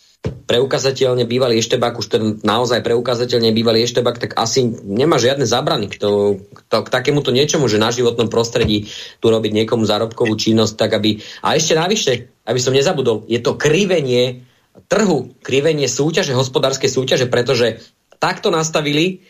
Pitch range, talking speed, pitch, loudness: 110-135 Hz, 150 wpm, 120 Hz, -16 LUFS